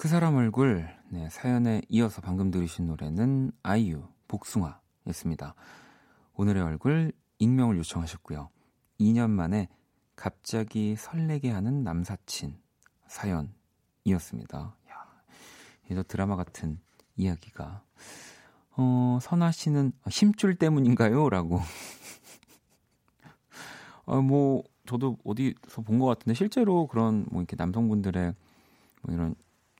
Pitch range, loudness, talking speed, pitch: 90-130 Hz, -28 LUFS, 240 characters per minute, 110 Hz